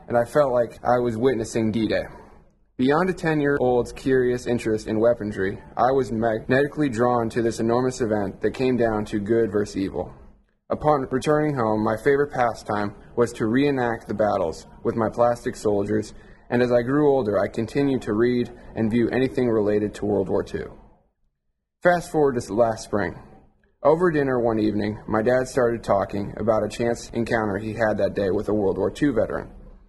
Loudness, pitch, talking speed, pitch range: -23 LUFS, 115 Hz, 185 wpm, 110-130 Hz